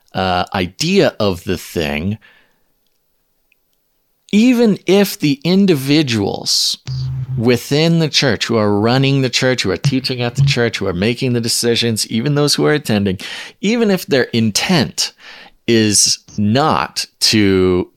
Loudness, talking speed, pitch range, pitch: -15 LUFS, 135 wpm, 105-145 Hz, 120 Hz